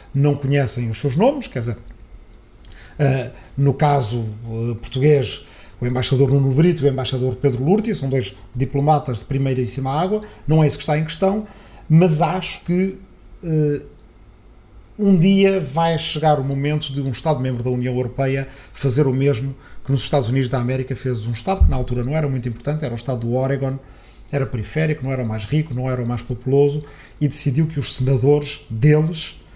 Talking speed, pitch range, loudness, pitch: 195 wpm, 125-150 Hz, -19 LUFS, 135 Hz